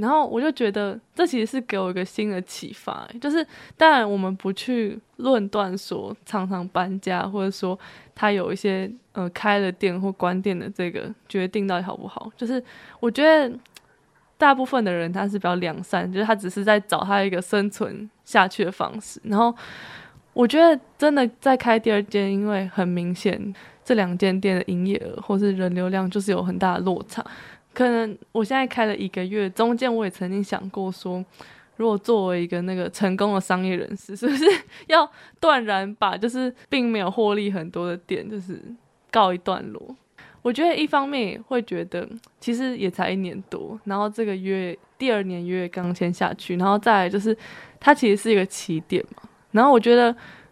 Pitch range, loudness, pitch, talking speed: 185-235 Hz, -23 LUFS, 205 Hz, 280 characters per minute